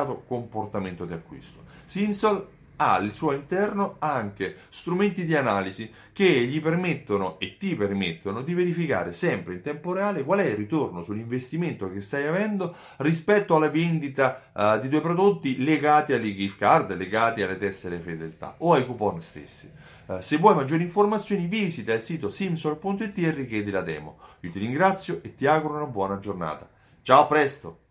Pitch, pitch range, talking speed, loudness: 145 Hz, 105-175 Hz, 160 wpm, -25 LUFS